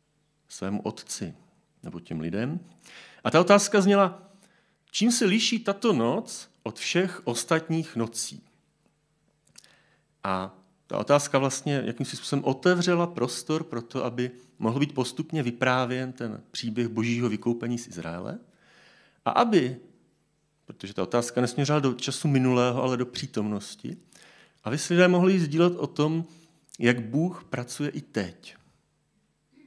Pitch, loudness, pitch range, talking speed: 135 Hz, -26 LUFS, 120-165 Hz, 130 wpm